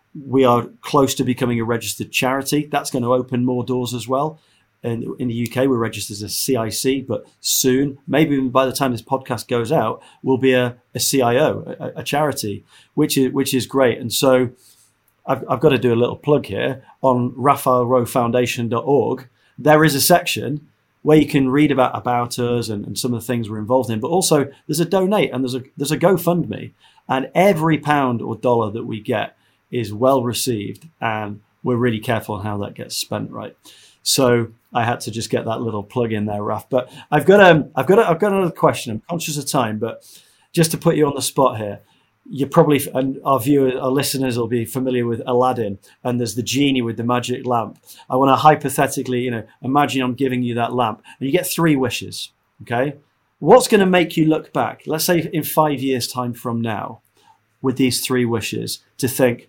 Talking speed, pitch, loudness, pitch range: 210 wpm, 130 Hz, -19 LUFS, 120-140 Hz